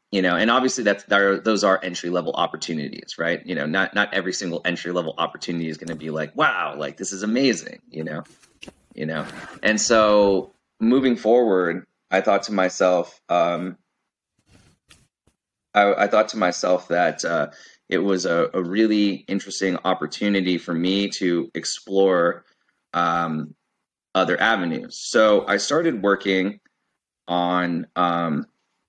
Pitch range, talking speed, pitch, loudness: 85-100 Hz, 150 wpm, 95 Hz, -21 LUFS